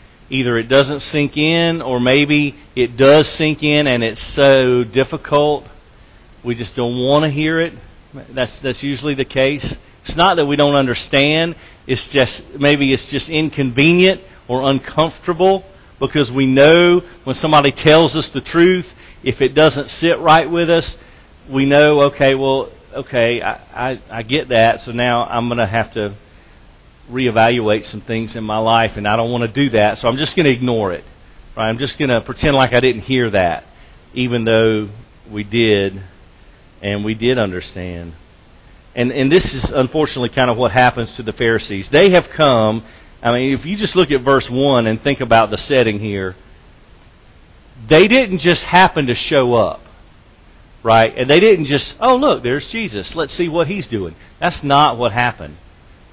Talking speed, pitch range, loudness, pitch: 175 wpm, 110-145 Hz, -15 LUFS, 125 Hz